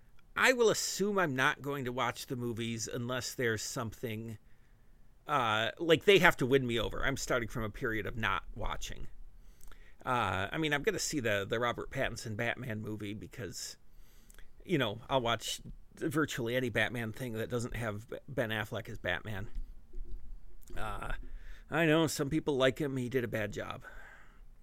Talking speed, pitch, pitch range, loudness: 170 wpm, 120 Hz, 110-140 Hz, -33 LUFS